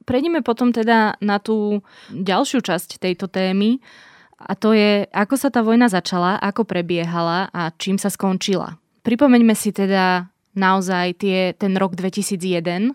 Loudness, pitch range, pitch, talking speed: -19 LUFS, 185-225 Hz, 195 Hz, 145 wpm